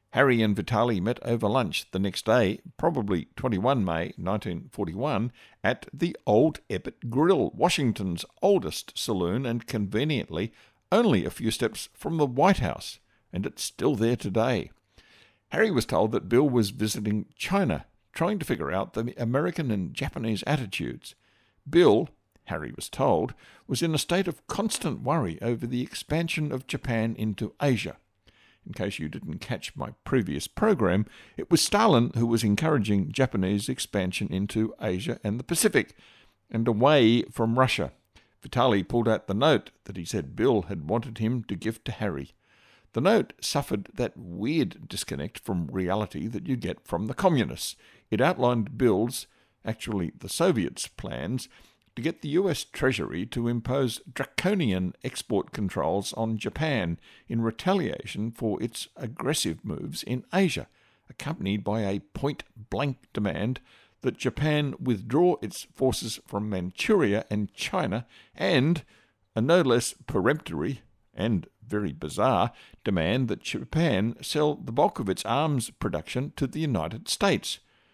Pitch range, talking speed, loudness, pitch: 105-140 Hz, 145 wpm, -27 LUFS, 115 Hz